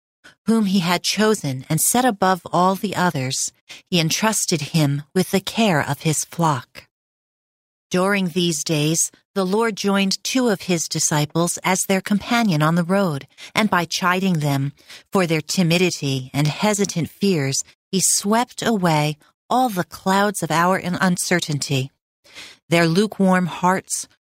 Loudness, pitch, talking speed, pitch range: -20 LUFS, 180 Hz, 145 wpm, 155-200 Hz